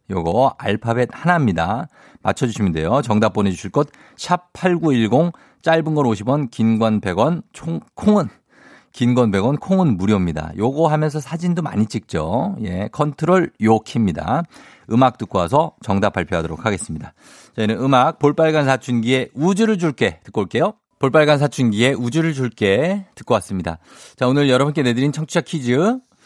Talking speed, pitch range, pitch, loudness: 320 characters per minute, 110-160 Hz, 130 Hz, -18 LUFS